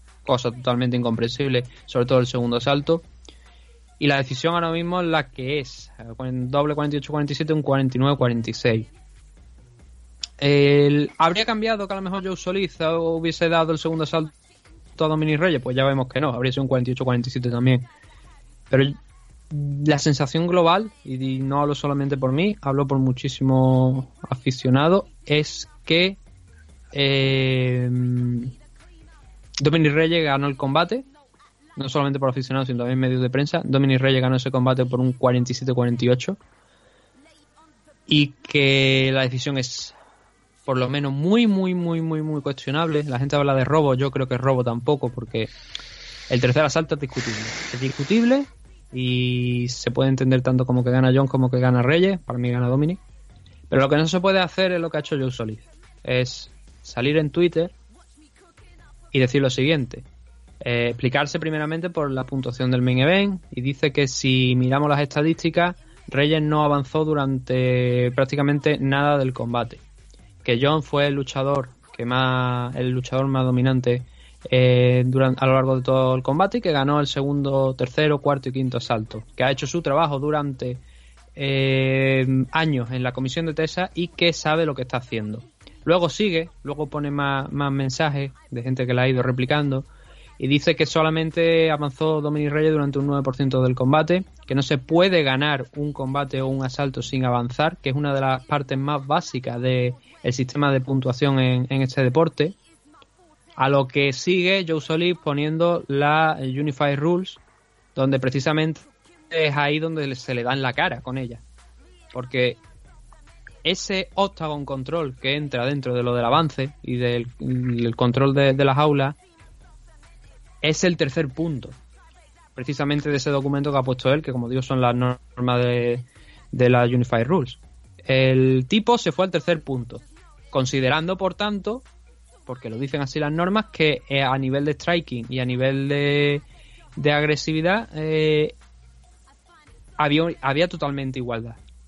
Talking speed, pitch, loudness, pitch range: 160 wpm, 135 Hz, -22 LUFS, 125-155 Hz